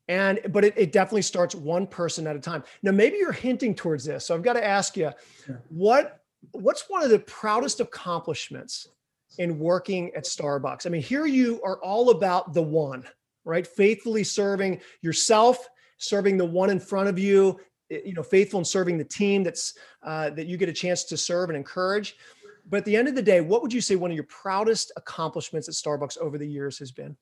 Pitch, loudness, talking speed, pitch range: 190 Hz, -25 LUFS, 210 wpm, 160-205 Hz